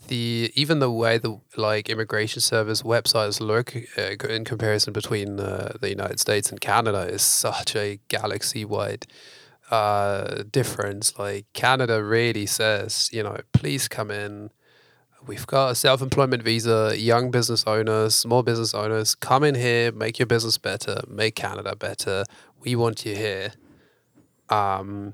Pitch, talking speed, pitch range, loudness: 115 Hz, 150 wpm, 105-120 Hz, -23 LUFS